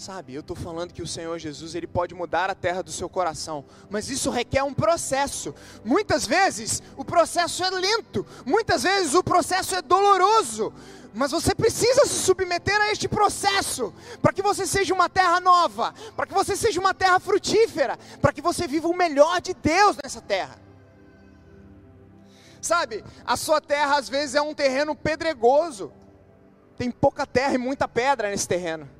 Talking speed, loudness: 170 wpm, -23 LUFS